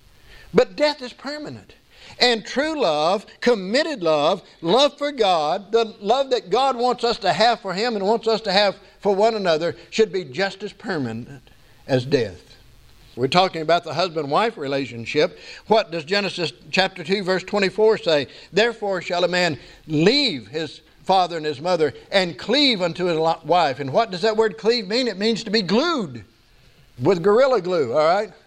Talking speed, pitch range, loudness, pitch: 175 wpm, 165-230 Hz, -20 LUFS, 195 Hz